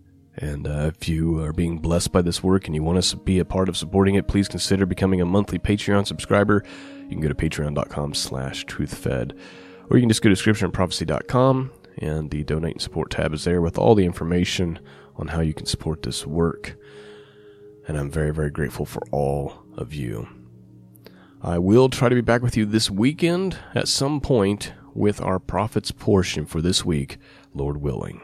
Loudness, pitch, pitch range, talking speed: -22 LUFS, 90 Hz, 75-105 Hz, 195 wpm